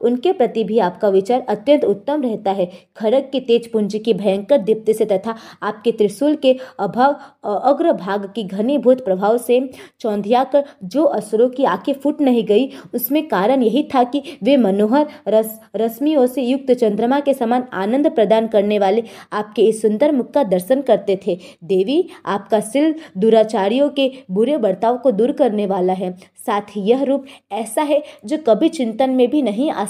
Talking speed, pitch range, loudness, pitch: 175 wpm, 210-275 Hz, -17 LUFS, 235 Hz